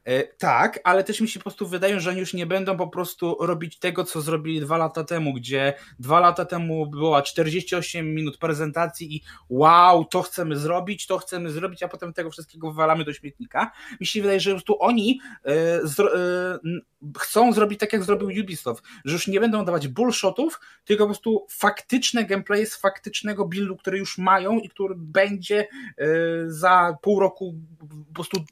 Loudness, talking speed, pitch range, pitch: -23 LUFS, 175 wpm, 165-205 Hz, 180 Hz